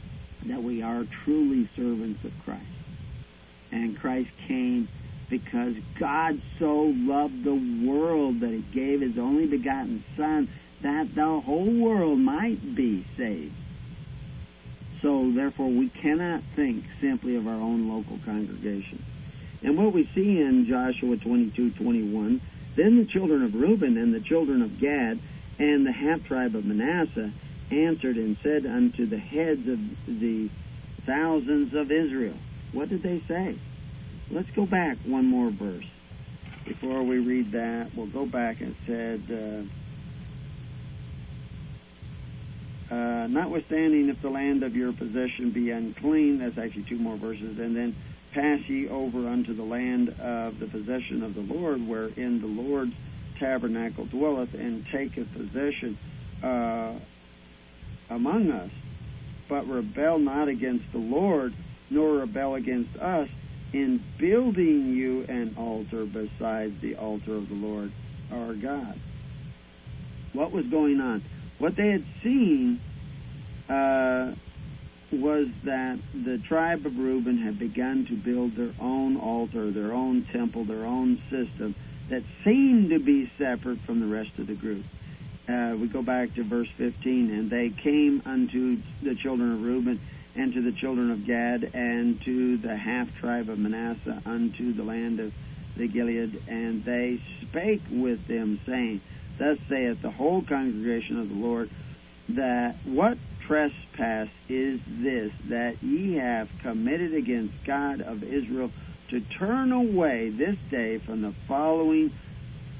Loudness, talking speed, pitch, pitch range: -27 LUFS, 140 wpm, 125 Hz, 115-150 Hz